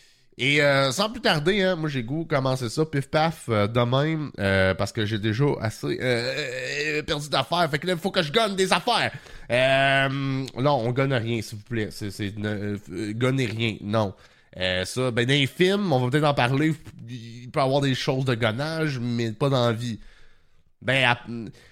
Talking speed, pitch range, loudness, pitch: 205 wpm, 115-150 Hz, -24 LUFS, 130 Hz